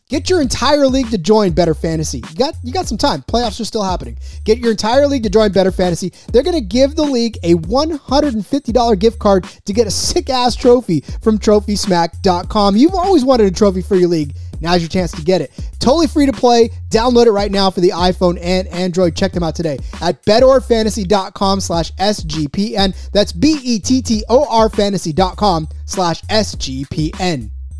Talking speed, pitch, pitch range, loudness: 180 wpm, 210 Hz, 180-245 Hz, -14 LUFS